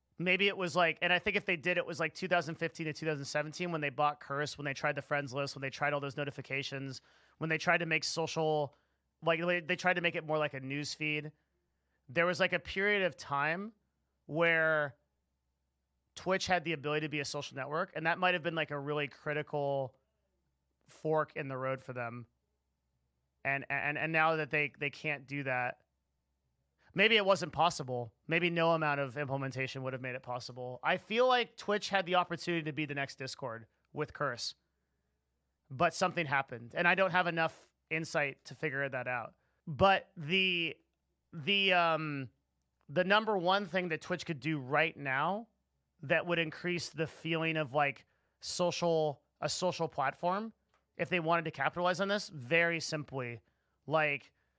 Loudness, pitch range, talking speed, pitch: -33 LUFS, 130-170 Hz, 180 wpm, 150 Hz